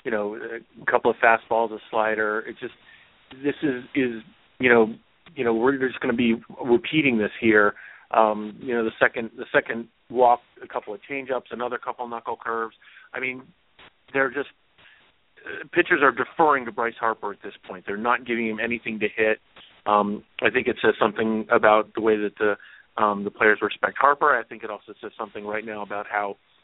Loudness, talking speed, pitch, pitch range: -23 LUFS, 200 wpm, 115 Hz, 105-120 Hz